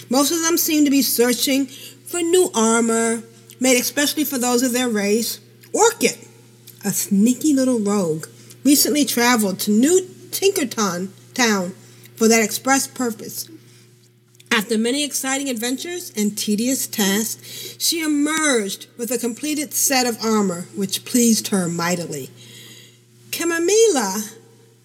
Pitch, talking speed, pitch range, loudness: 230 Hz, 125 wpm, 190-270 Hz, -19 LUFS